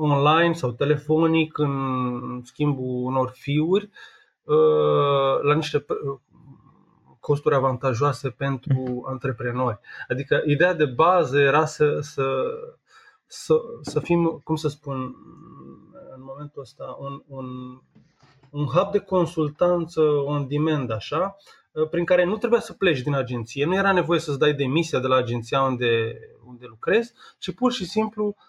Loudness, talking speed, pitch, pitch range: -23 LUFS, 130 wpm, 145 Hz, 130-170 Hz